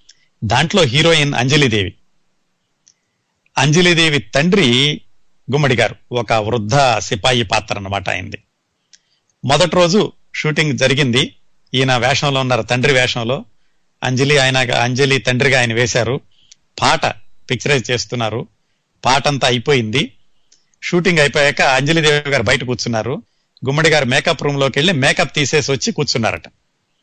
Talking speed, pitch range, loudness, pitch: 110 wpm, 125-150 Hz, -15 LUFS, 135 Hz